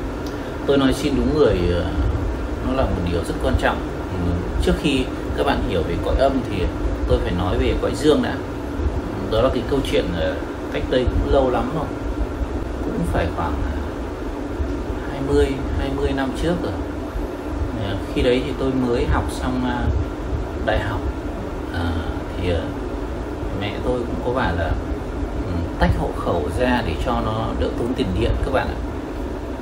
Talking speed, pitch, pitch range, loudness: 155 wpm, 95 Hz, 85-125 Hz, -22 LUFS